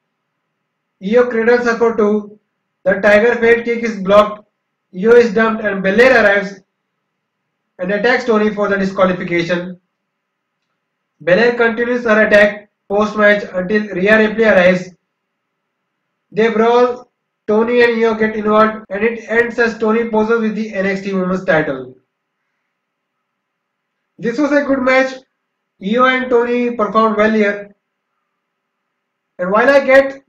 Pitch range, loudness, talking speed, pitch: 200-235 Hz, -13 LUFS, 130 wpm, 215 Hz